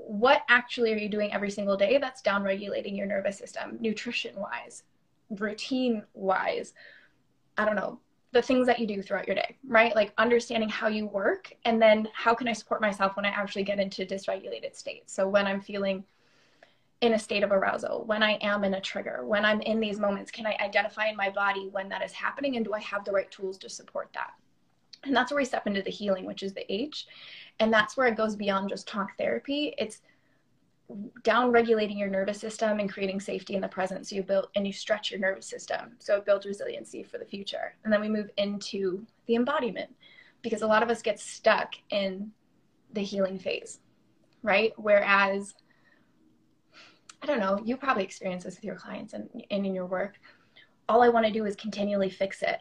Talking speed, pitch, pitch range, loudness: 205 wpm, 210 Hz, 200-230 Hz, -28 LUFS